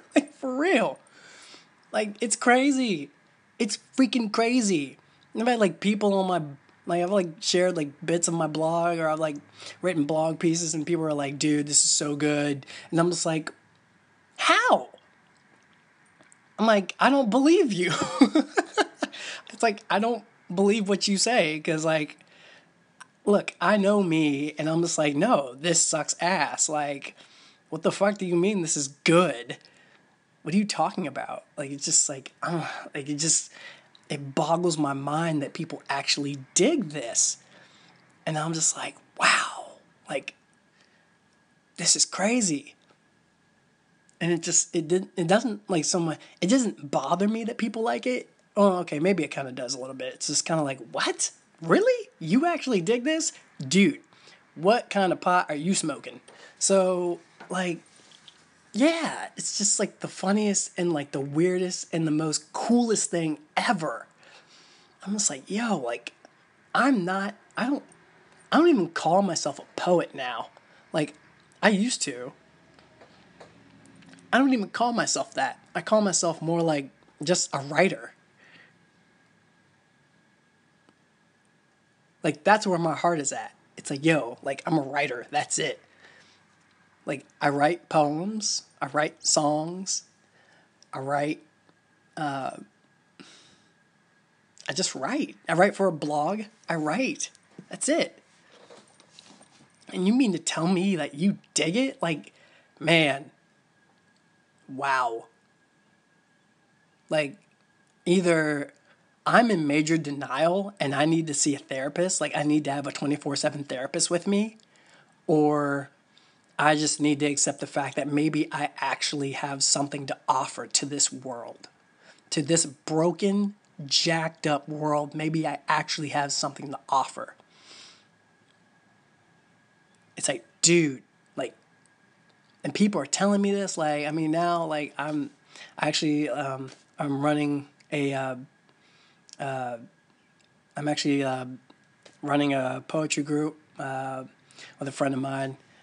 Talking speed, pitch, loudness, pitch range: 145 wpm, 170 Hz, -26 LUFS, 150-200 Hz